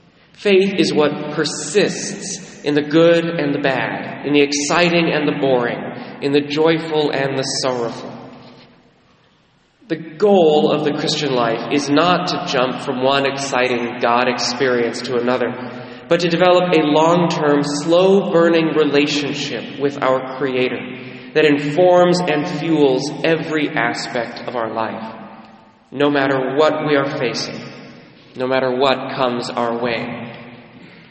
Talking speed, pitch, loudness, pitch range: 140 wpm, 145 Hz, -17 LUFS, 125-155 Hz